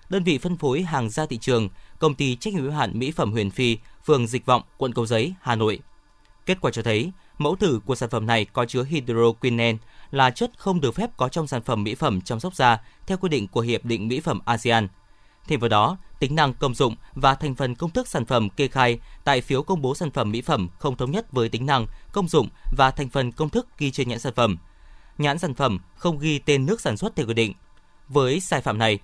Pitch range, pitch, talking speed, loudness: 115-150 Hz, 130 Hz, 250 wpm, -23 LUFS